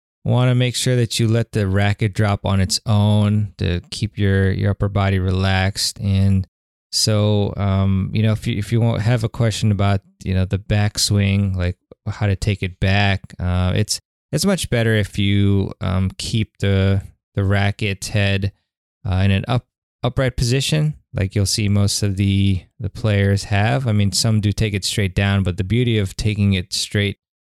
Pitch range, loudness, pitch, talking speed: 95-110 Hz, -19 LUFS, 100 Hz, 190 wpm